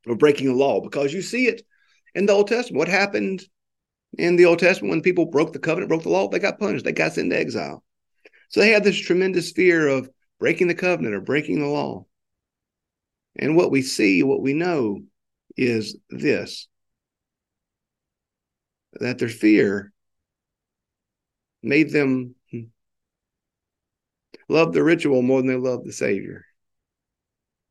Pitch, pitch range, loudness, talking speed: 145 Hz, 125-185 Hz, -20 LUFS, 155 wpm